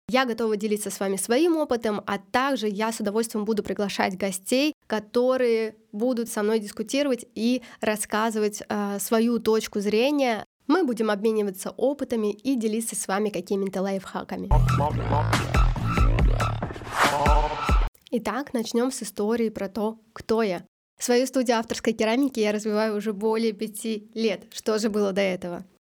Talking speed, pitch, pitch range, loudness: 135 wpm, 220 Hz, 205-235 Hz, -25 LUFS